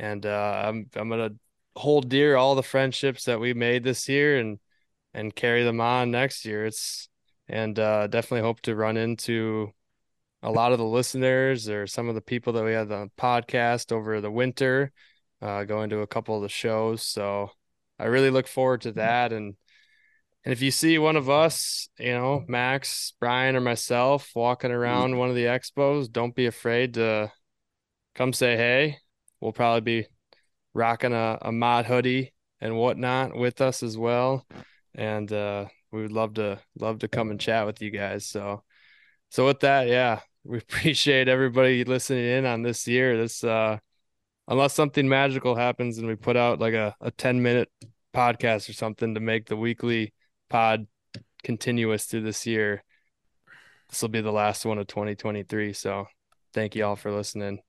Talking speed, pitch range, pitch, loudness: 180 wpm, 110-125 Hz, 115 Hz, -25 LUFS